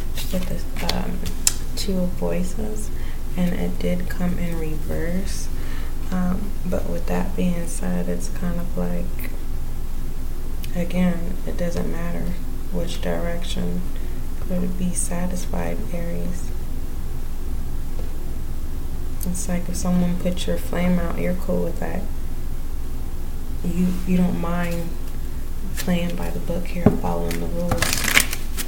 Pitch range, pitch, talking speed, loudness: 60-90 Hz, 80 Hz, 115 wpm, -26 LUFS